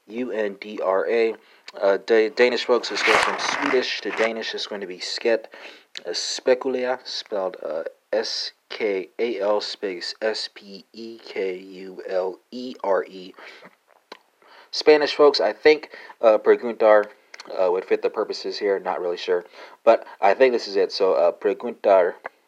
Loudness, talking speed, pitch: -22 LUFS, 120 wpm, 390 Hz